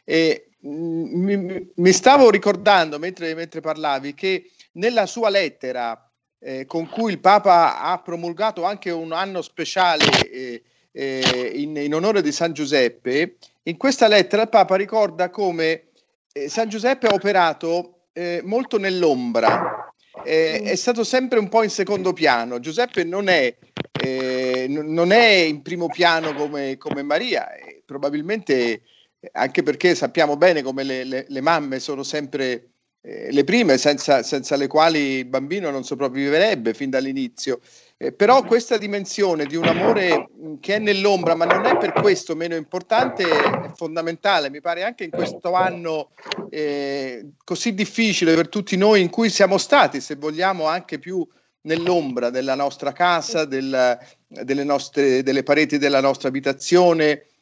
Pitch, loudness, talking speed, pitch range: 165 Hz, -20 LUFS, 150 wpm, 140-195 Hz